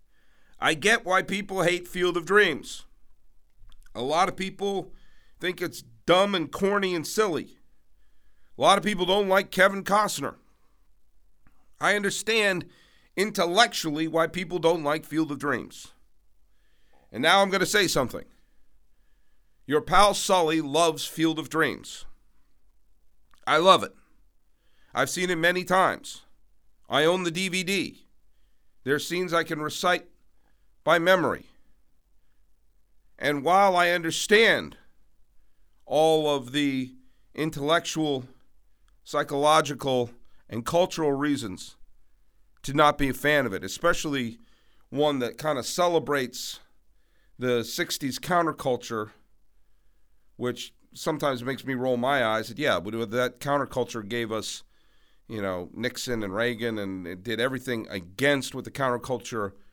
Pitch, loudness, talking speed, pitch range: 150 Hz, -25 LUFS, 125 wpm, 120-180 Hz